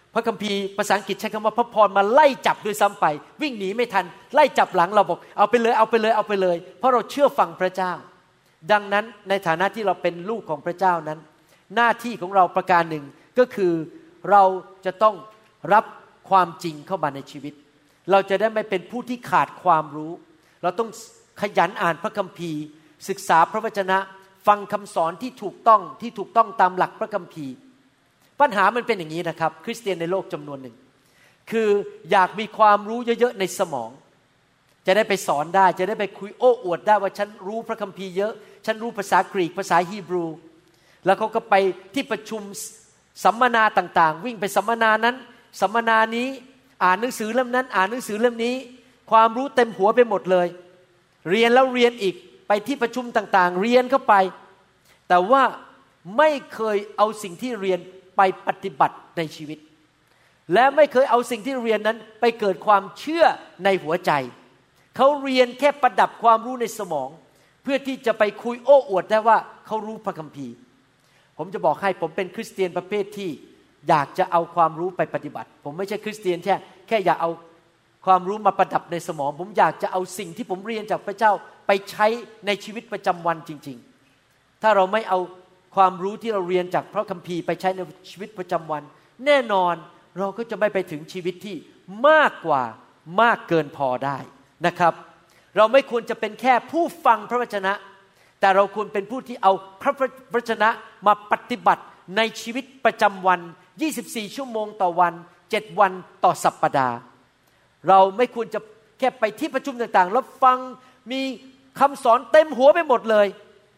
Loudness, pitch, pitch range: -21 LUFS, 200 Hz, 180-225 Hz